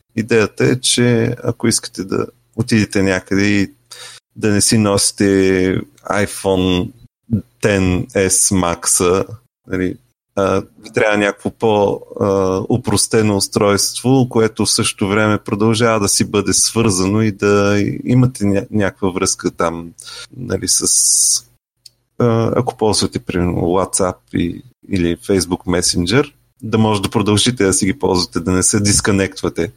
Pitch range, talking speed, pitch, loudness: 95-115 Hz, 120 wpm, 105 Hz, -15 LUFS